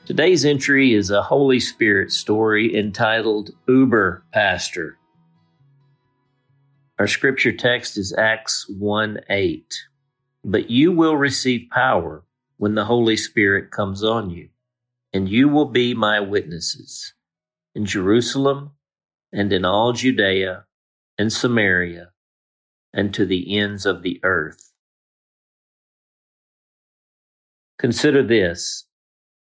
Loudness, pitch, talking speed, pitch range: -19 LUFS, 115 Hz, 105 wpm, 105-140 Hz